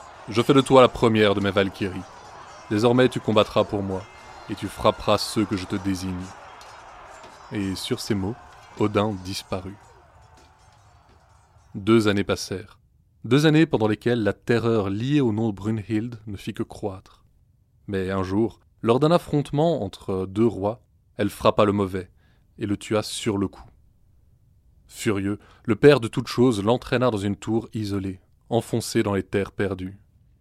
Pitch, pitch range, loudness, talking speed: 105 Hz, 95-115 Hz, -23 LUFS, 160 wpm